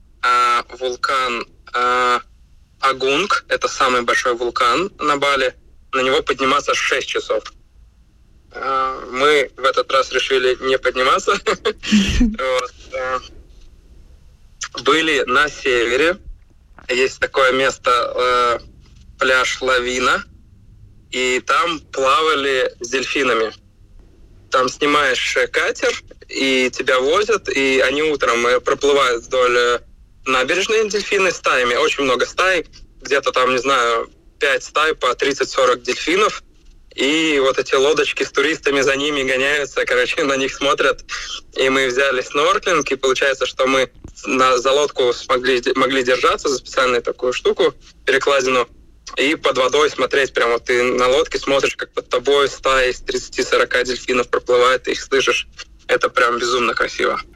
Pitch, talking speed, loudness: 140 Hz, 125 wpm, -17 LUFS